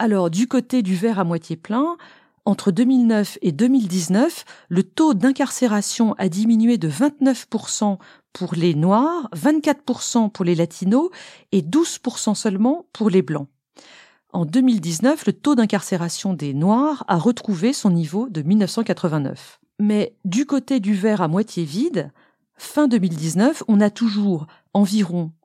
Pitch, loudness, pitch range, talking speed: 210 Hz, -20 LUFS, 185-250 Hz, 140 wpm